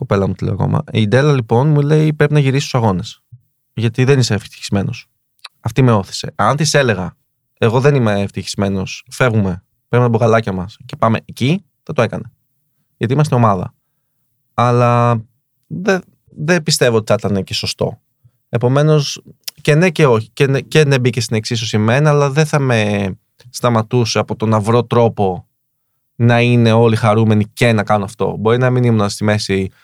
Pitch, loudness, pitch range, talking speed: 120 Hz, -15 LUFS, 110-135 Hz, 175 wpm